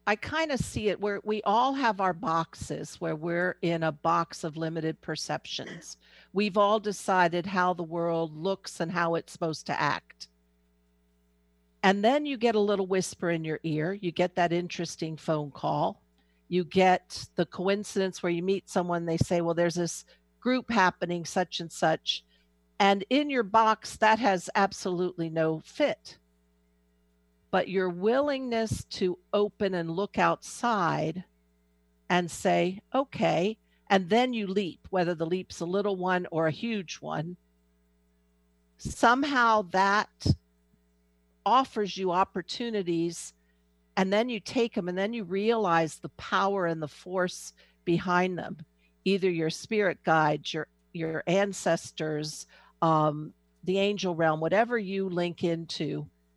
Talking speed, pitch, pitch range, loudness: 145 wpm, 175 Hz, 155-200 Hz, -28 LUFS